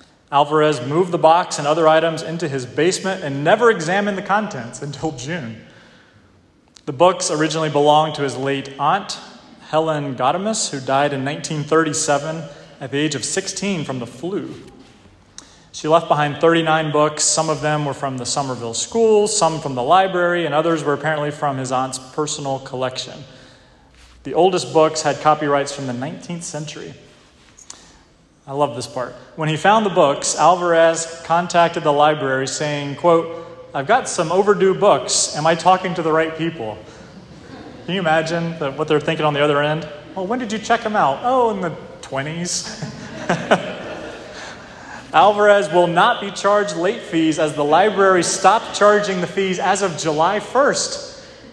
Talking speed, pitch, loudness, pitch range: 165 wpm, 155 Hz, -18 LUFS, 145-175 Hz